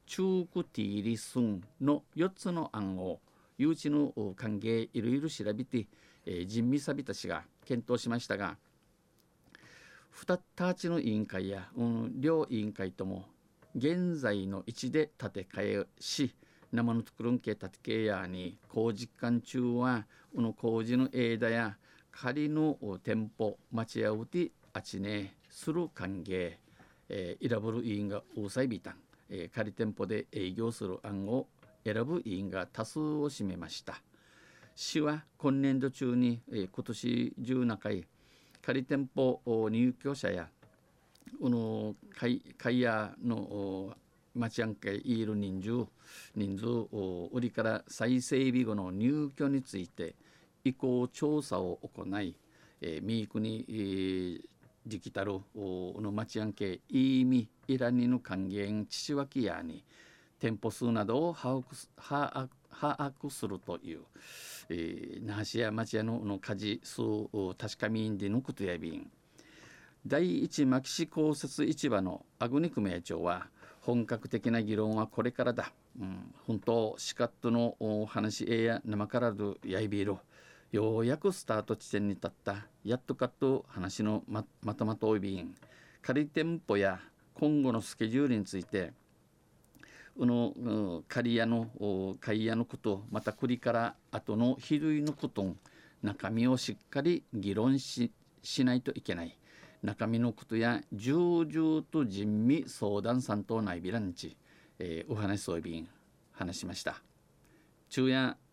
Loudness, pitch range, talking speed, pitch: -34 LUFS, 105-130 Hz, 240 characters per minute, 115 Hz